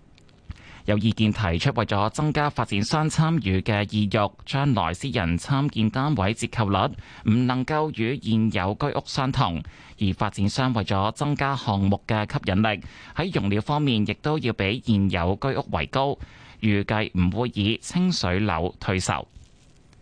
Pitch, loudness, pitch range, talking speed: 110 Hz, -24 LUFS, 100-135 Hz, 230 characters per minute